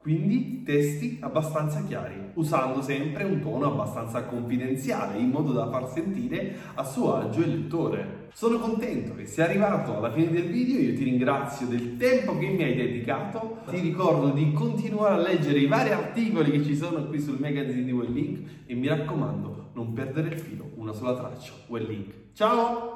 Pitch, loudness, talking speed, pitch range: 150 Hz, -27 LUFS, 180 wpm, 130-175 Hz